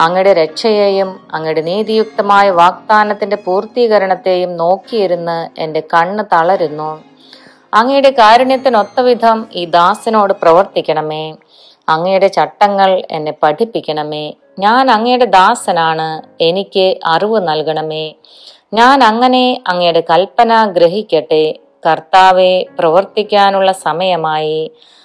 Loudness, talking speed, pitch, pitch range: -11 LUFS, 80 wpm, 185 Hz, 160-215 Hz